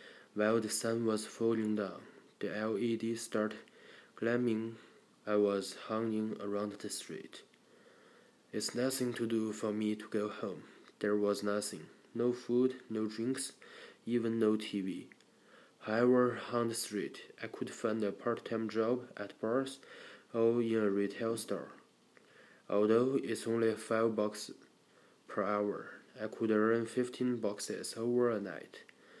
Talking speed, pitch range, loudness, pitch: 140 wpm, 105-115 Hz, -35 LUFS, 110 Hz